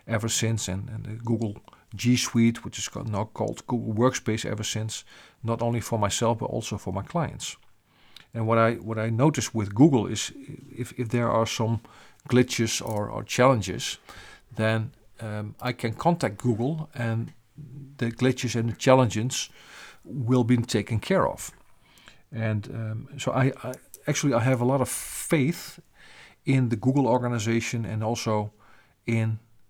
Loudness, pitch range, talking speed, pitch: -26 LUFS, 110-125 Hz, 160 wpm, 115 Hz